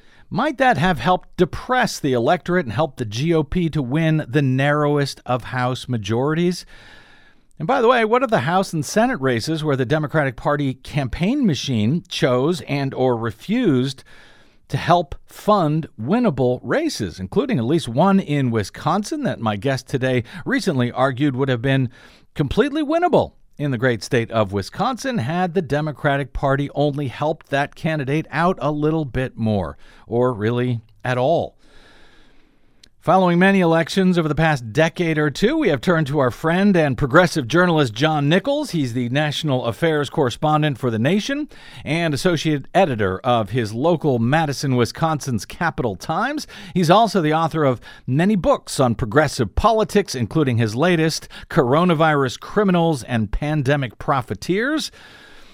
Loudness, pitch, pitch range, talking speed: -20 LUFS, 150 Hz, 130-175 Hz, 150 wpm